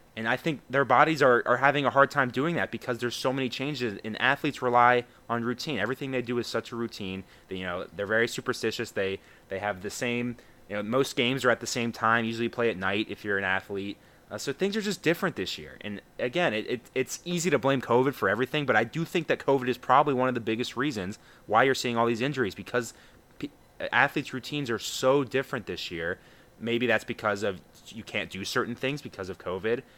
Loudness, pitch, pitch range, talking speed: -27 LUFS, 120 Hz, 110-135 Hz, 235 wpm